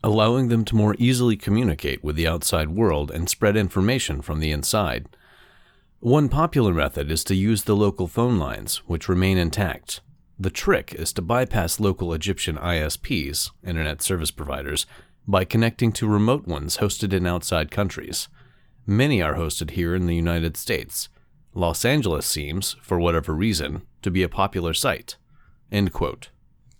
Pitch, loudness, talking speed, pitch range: 95 Hz, -23 LUFS, 155 wpm, 80-110 Hz